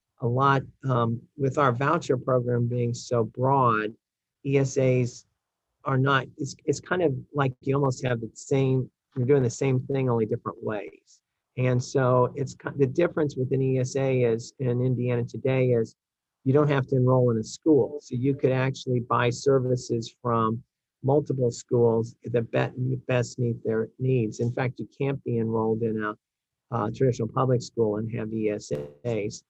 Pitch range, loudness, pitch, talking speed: 115-135 Hz, -26 LUFS, 125 Hz, 170 wpm